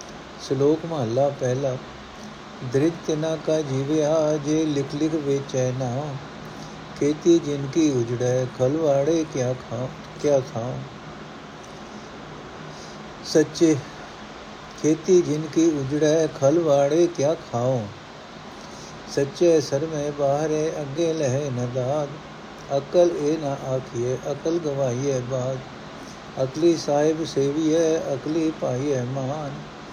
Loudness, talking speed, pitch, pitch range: -23 LUFS, 85 wpm, 145 Hz, 130-160 Hz